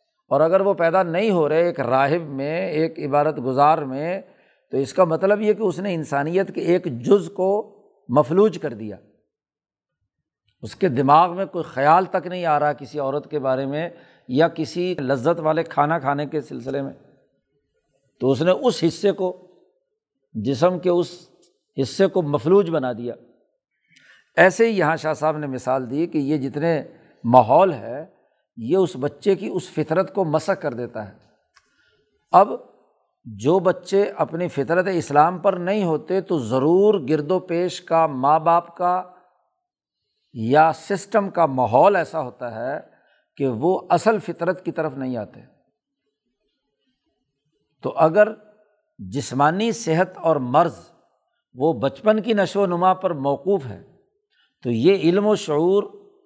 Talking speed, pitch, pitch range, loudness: 155 wpm, 165 Hz, 140-190 Hz, -20 LUFS